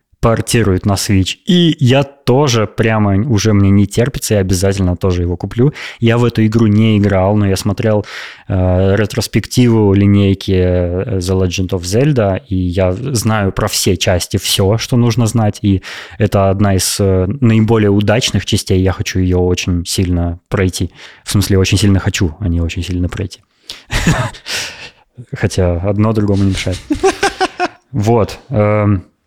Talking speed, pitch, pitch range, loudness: 150 wpm, 100 Hz, 95-115 Hz, -13 LUFS